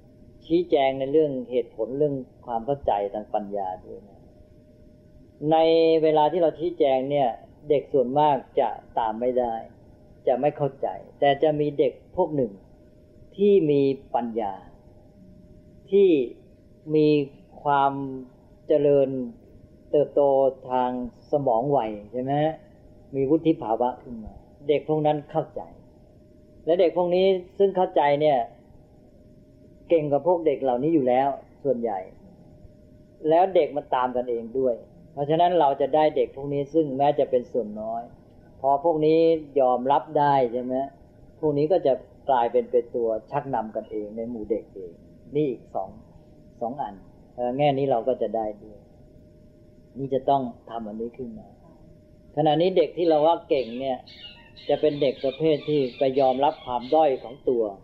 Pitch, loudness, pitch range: 135 Hz, -24 LUFS, 120-155 Hz